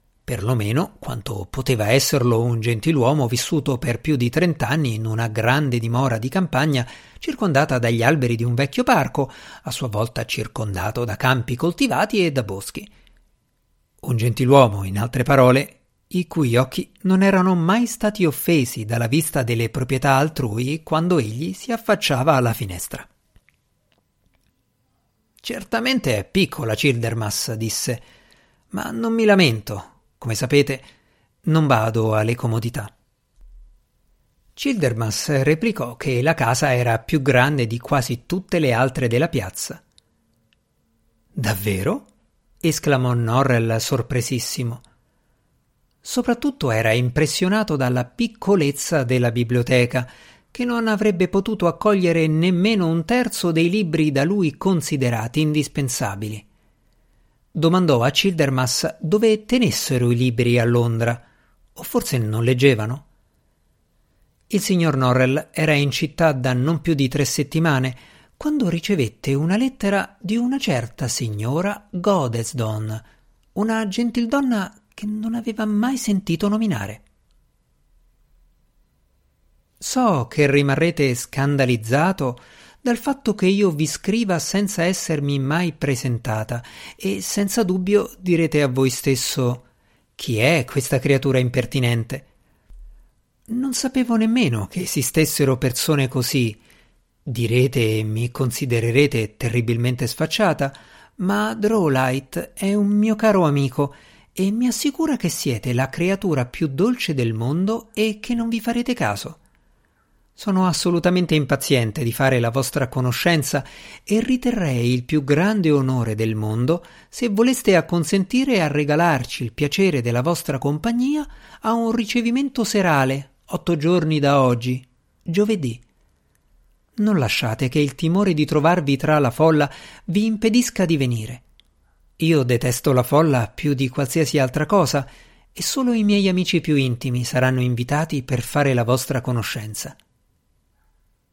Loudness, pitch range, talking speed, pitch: -20 LUFS, 125-185 Hz, 125 wpm, 140 Hz